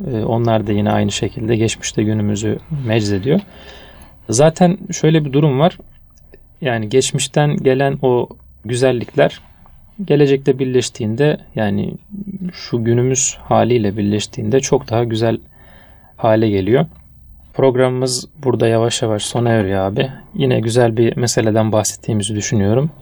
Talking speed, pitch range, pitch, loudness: 110 wpm, 105-135 Hz, 115 Hz, -16 LUFS